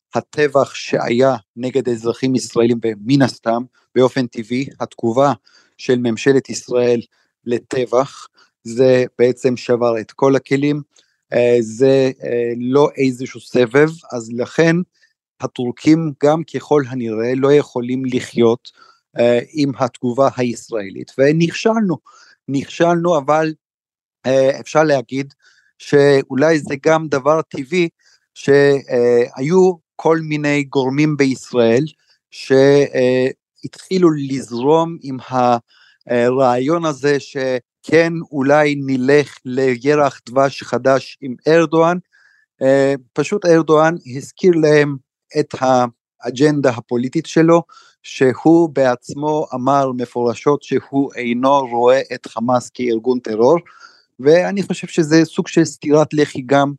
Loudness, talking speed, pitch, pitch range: -16 LUFS, 95 wpm, 135 Hz, 125-155 Hz